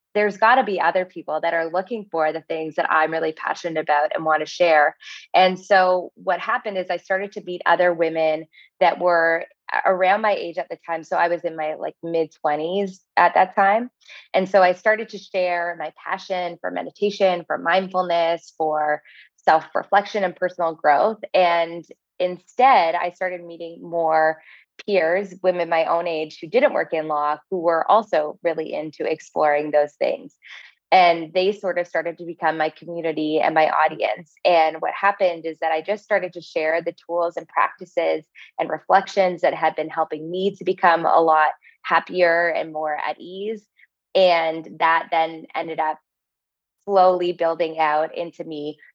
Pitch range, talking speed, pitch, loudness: 160-185 Hz, 175 wpm, 170 Hz, -21 LUFS